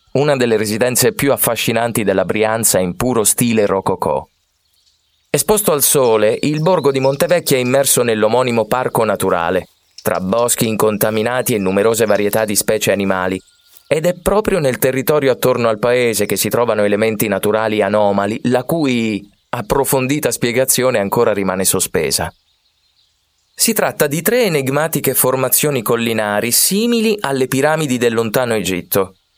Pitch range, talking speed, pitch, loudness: 100-135 Hz, 135 wpm, 115 Hz, -15 LUFS